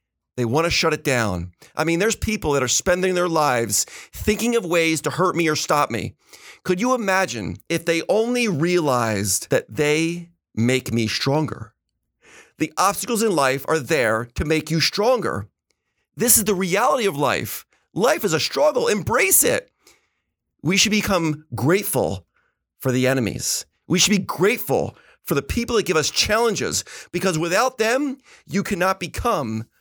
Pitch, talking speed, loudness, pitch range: 160 Hz, 165 wpm, -20 LUFS, 130-190 Hz